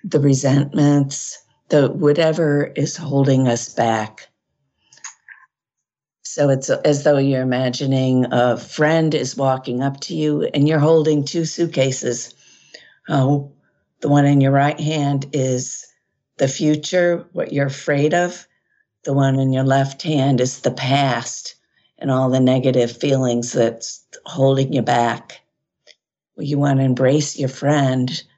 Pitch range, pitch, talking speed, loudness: 130-150 Hz, 140 Hz, 135 wpm, -18 LUFS